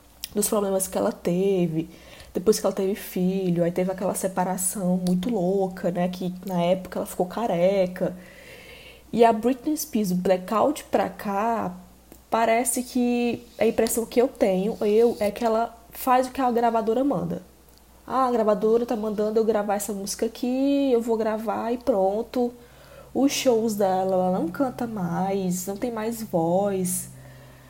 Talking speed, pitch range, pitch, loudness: 160 wpm, 185-235 Hz, 215 Hz, -24 LUFS